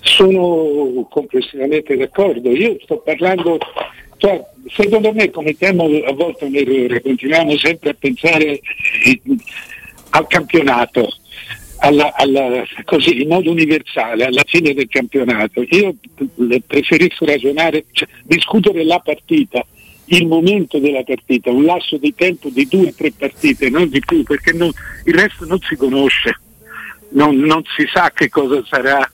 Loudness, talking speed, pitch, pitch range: -14 LUFS, 140 wpm, 155 Hz, 135-175 Hz